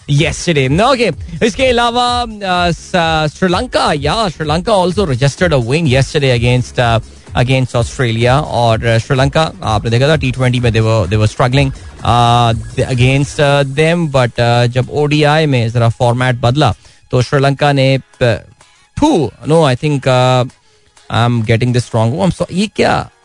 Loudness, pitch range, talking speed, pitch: -13 LUFS, 120-155 Hz, 155 wpm, 135 Hz